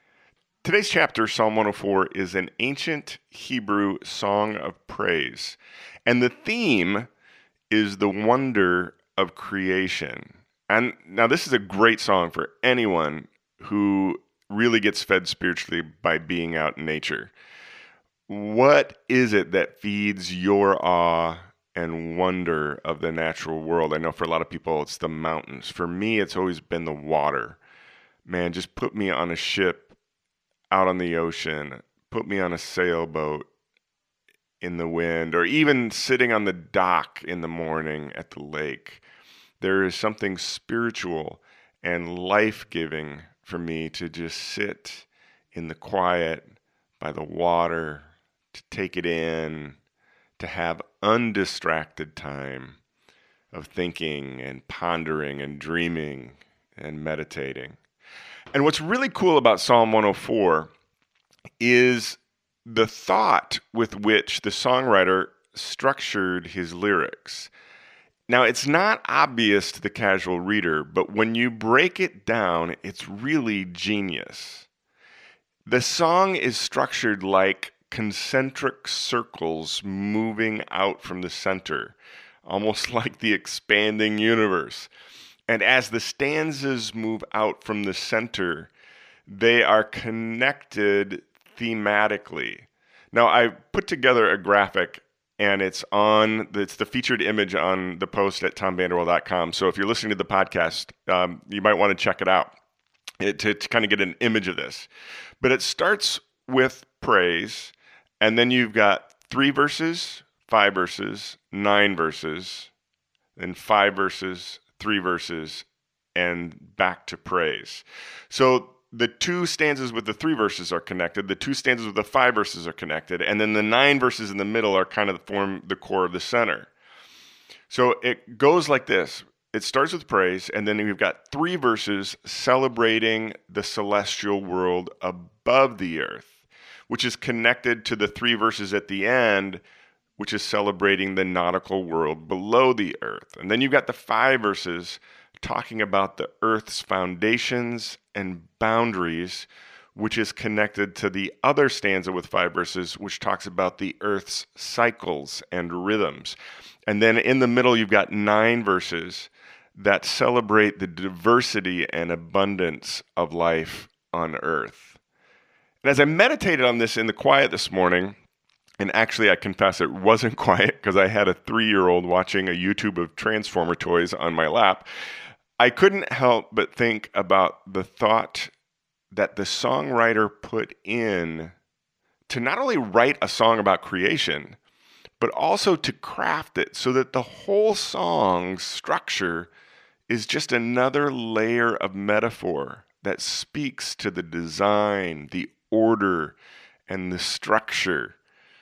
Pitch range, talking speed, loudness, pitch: 90-115 Hz, 145 wpm, -23 LUFS, 100 Hz